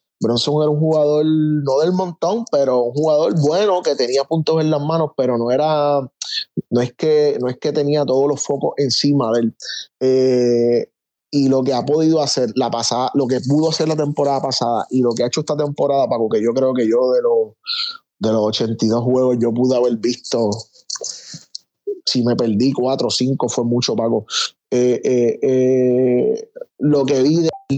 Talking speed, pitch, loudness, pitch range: 190 wpm, 140 Hz, -17 LUFS, 125-155 Hz